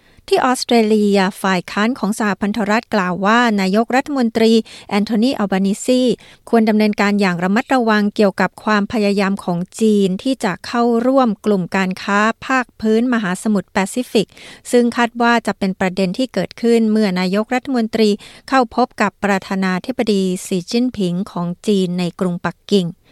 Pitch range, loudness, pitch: 195-235 Hz, -17 LUFS, 210 Hz